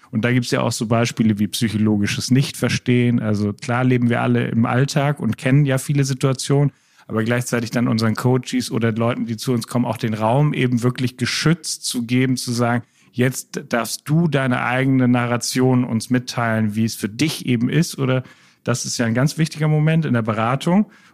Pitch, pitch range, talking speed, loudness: 125 Hz, 115-135 Hz, 195 wpm, -19 LUFS